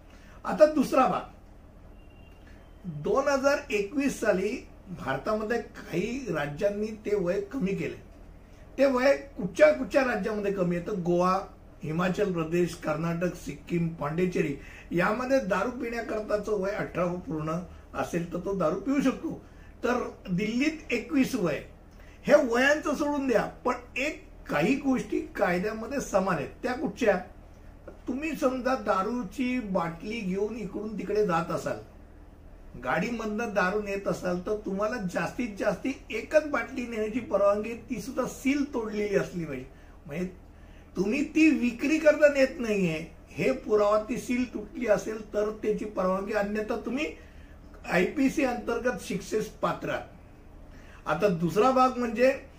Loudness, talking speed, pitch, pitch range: -28 LUFS, 125 wpm, 210 Hz, 180-250 Hz